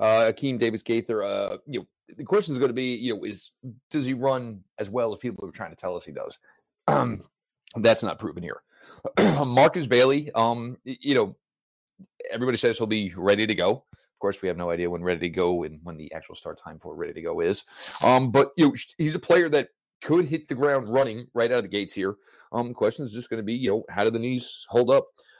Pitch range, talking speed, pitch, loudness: 110-145 Hz, 245 wpm, 125 Hz, -25 LUFS